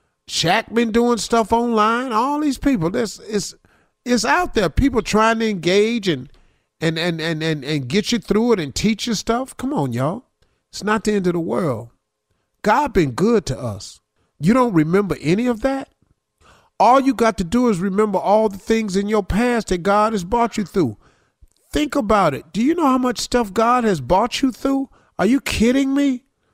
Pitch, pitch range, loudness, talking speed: 215 Hz, 180-240 Hz, -19 LUFS, 200 wpm